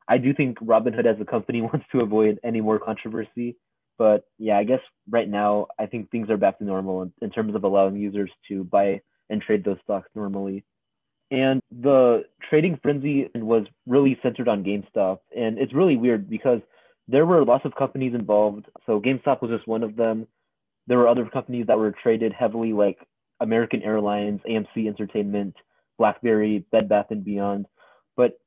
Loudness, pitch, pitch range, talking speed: -23 LUFS, 110 Hz, 105-120 Hz, 180 wpm